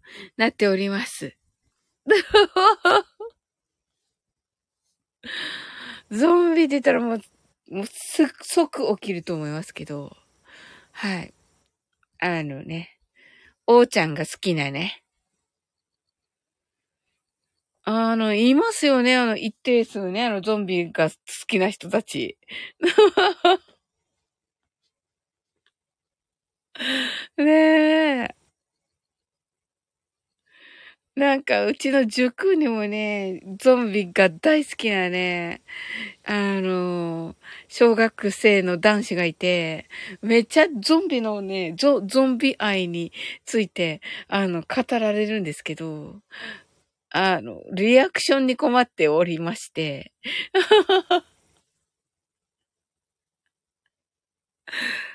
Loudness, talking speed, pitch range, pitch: -21 LUFS, 155 characters per minute, 185-295 Hz, 220 Hz